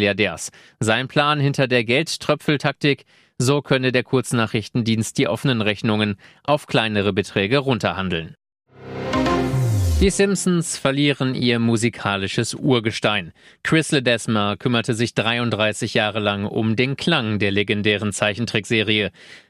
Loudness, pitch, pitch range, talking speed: -20 LUFS, 120 Hz, 105-135 Hz, 110 wpm